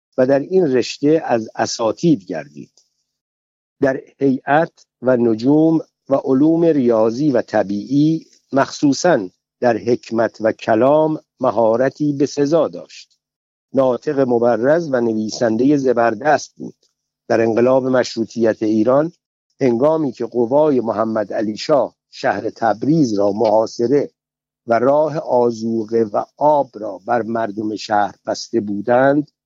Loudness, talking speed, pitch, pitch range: -17 LUFS, 115 wpm, 120 Hz, 115-140 Hz